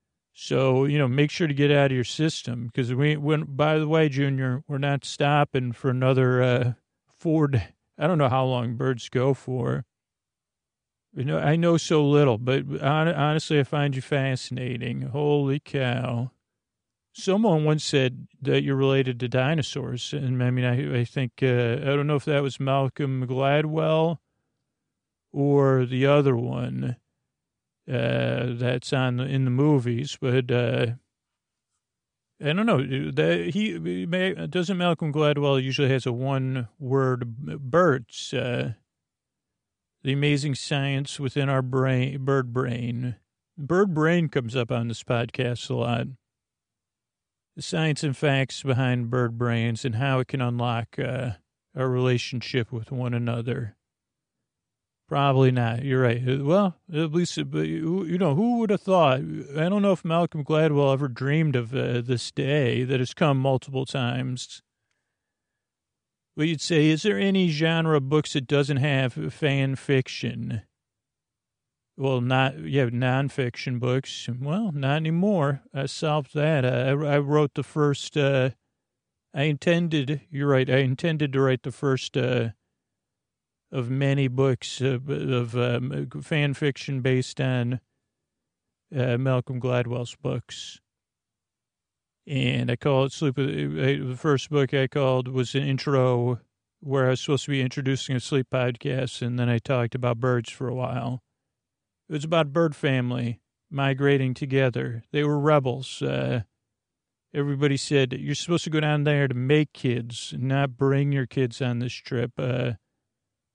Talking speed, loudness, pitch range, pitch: 150 wpm, -25 LUFS, 125-145 Hz, 135 Hz